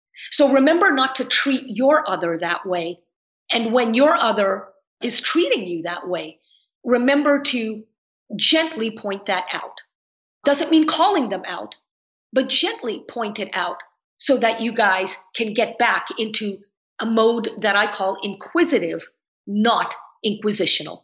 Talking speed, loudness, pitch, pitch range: 145 wpm, -19 LUFS, 225 Hz, 195-270 Hz